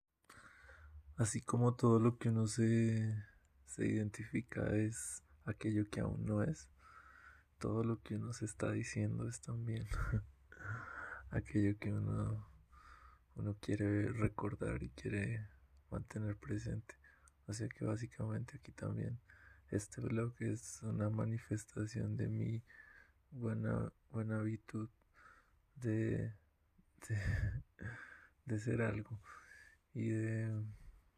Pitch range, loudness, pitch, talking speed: 105-115 Hz, -40 LUFS, 110 Hz, 110 wpm